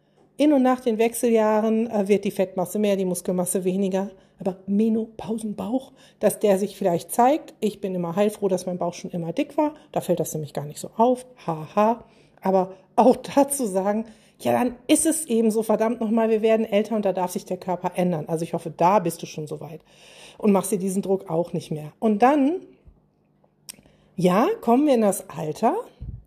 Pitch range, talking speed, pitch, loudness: 180-225 Hz, 200 wpm, 205 Hz, -23 LUFS